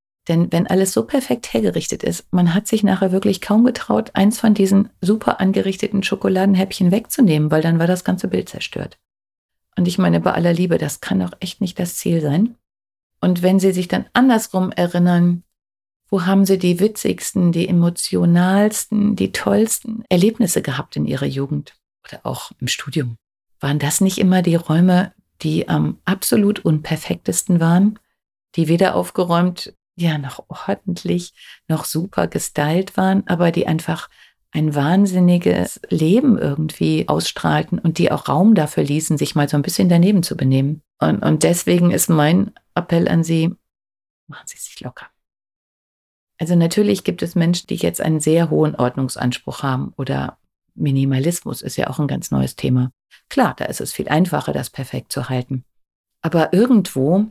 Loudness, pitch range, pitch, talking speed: -18 LUFS, 155-195 Hz, 175 Hz, 160 wpm